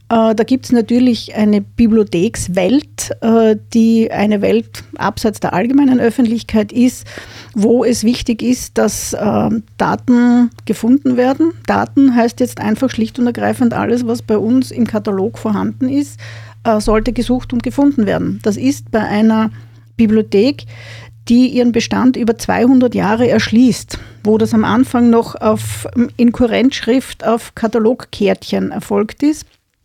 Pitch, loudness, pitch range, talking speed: 230 Hz, -14 LUFS, 215-245 Hz, 130 wpm